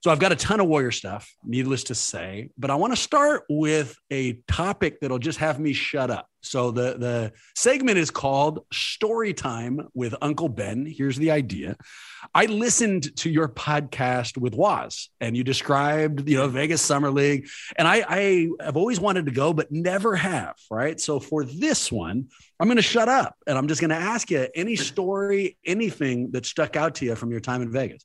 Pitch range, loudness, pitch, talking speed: 125-165 Hz, -24 LUFS, 145 Hz, 205 wpm